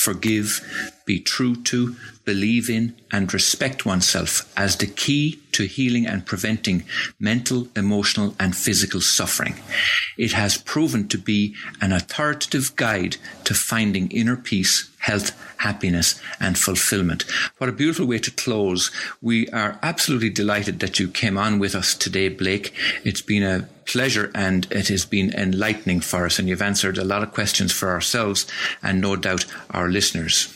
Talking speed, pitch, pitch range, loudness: 155 wpm, 105 Hz, 95-115 Hz, -21 LUFS